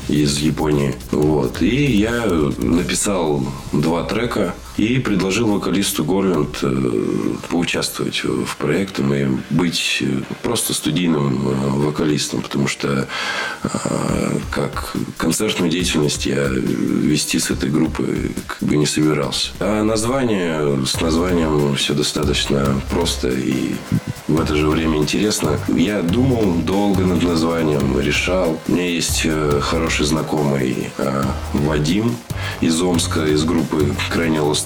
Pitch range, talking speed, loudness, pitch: 65-80 Hz, 115 wpm, -18 LUFS, 75 Hz